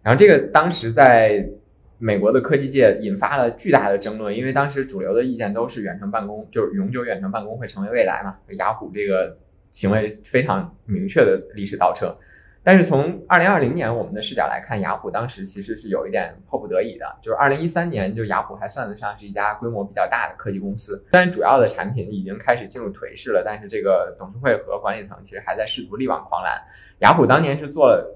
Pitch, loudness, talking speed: 115 Hz, -20 LUFS, 350 characters per minute